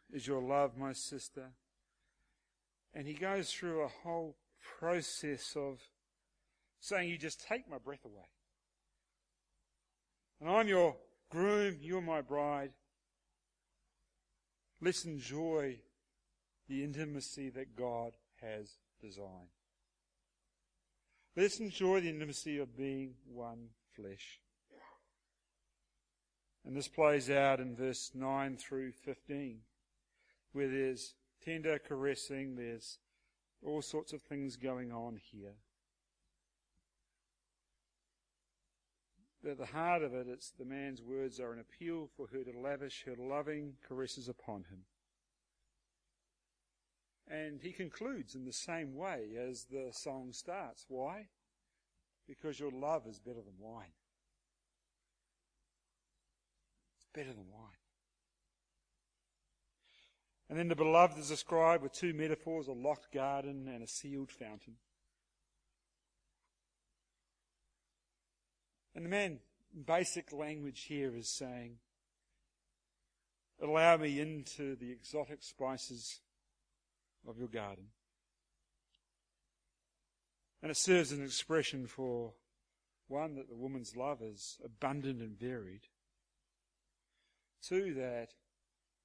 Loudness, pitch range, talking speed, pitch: -39 LUFS, 120-155 Hz, 110 wpm, 135 Hz